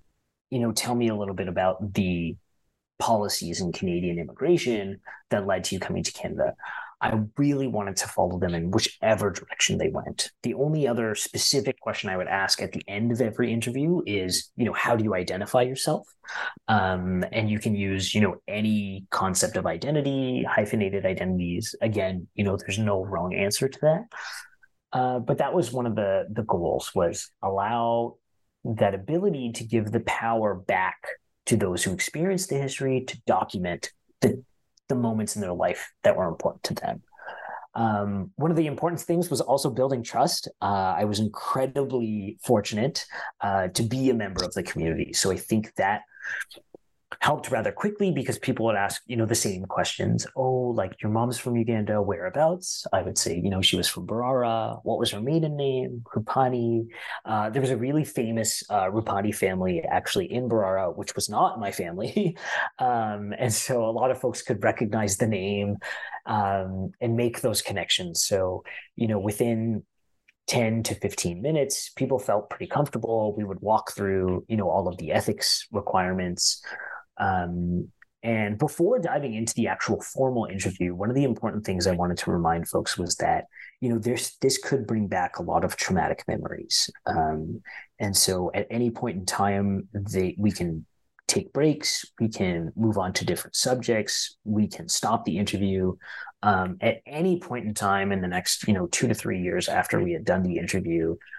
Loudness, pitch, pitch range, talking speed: -26 LUFS, 110 Hz, 100-130 Hz, 180 wpm